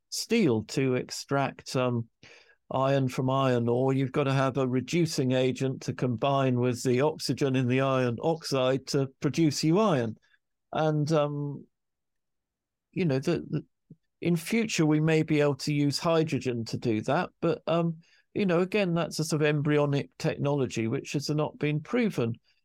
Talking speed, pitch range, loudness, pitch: 160 wpm, 130-160 Hz, -28 LUFS, 145 Hz